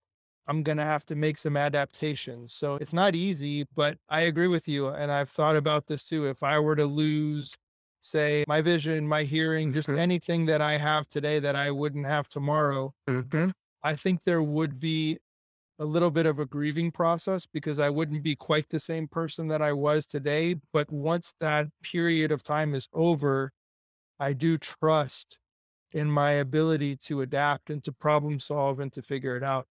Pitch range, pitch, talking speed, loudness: 145-160 Hz, 150 Hz, 190 wpm, -28 LUFS